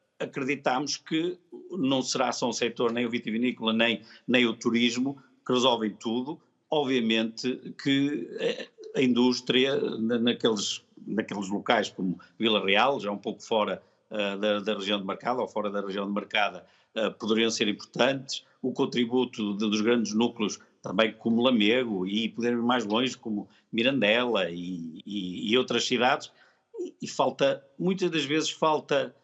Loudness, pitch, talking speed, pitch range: -27 LUFS, 120 Hz, 150 wpm, 110-140 Hz